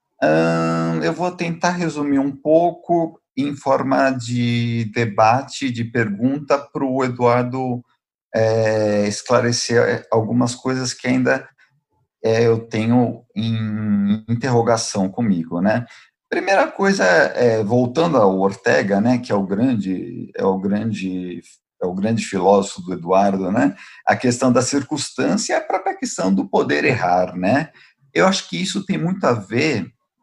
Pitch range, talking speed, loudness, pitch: 100-135 Hz, 140 wpm, -19 LUFS, 120 Hz